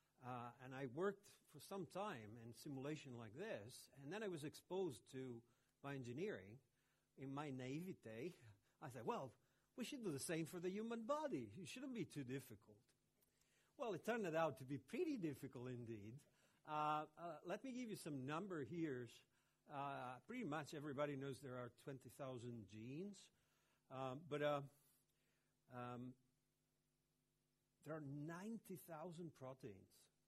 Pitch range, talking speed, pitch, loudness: 125-175 Hz, 145 wpm, 140 Hz, -51 LUFS